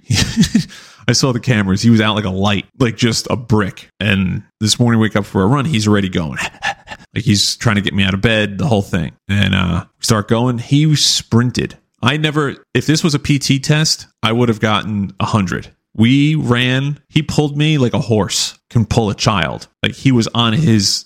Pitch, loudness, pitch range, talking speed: 115 Hz, -15 LUFS, 105-135 Hz, 210 wpm